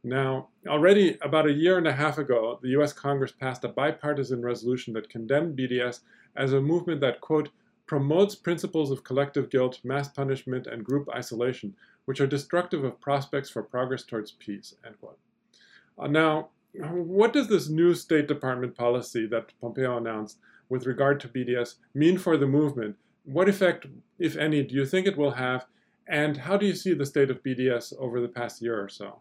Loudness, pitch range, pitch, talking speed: -27 LUFS, 125-155 Hz, 140 Hz, 185 wpm